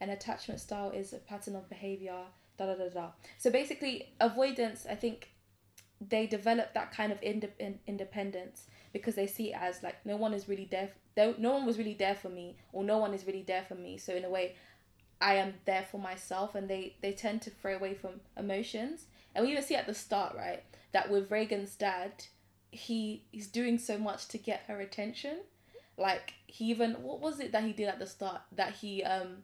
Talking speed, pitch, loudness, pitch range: 210 wpm, 200 Hz, -36 LUFS, 190-220 Hz